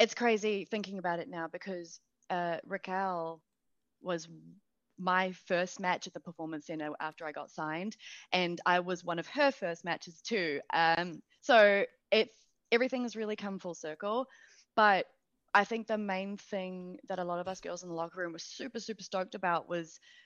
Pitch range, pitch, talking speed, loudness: 170-210 Hz, 185 Hz, 180 wpm, -33 LUFS